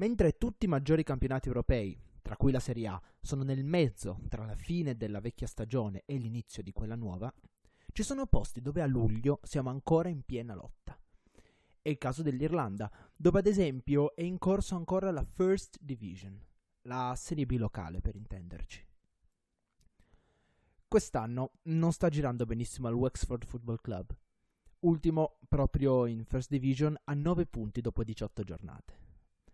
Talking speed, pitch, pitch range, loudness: 155 wpm, 130 Hz, 110-155 Hz, -34 LUFS